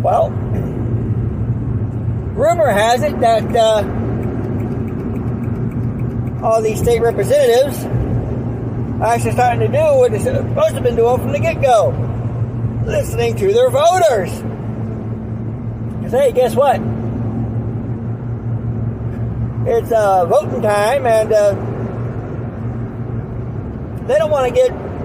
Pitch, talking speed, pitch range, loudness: 120 Hz, 110 wpm, 115-125 Hz, -17 LUFS